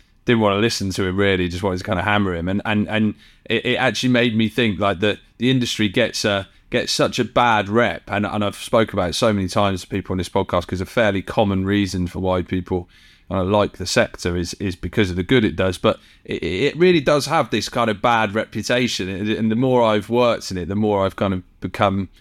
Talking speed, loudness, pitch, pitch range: 250 wpm, -20 LUFS, 100 Hz, 95-115 Hz